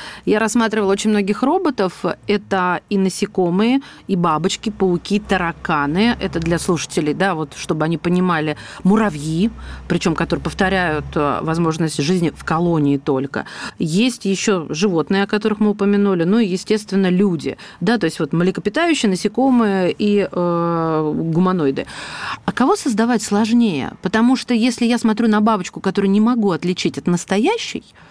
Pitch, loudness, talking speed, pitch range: 190 Hz, -18 LUFS, 140 wpm, 170-215 Hz